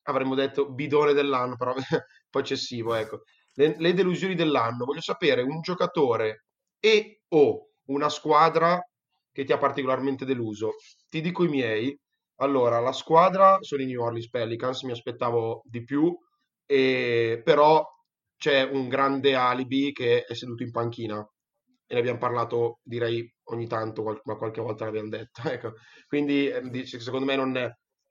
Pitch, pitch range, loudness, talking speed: 135 Hz, 120-155 Hz, -25 LUFS, 150 wpm